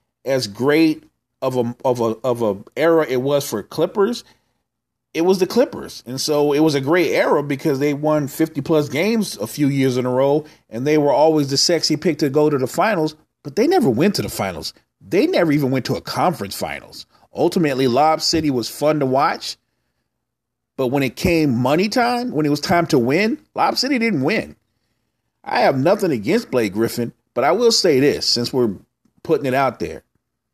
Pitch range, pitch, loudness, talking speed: 125-160 Hz, 145 Hz, -18 LUFS, 200 wpm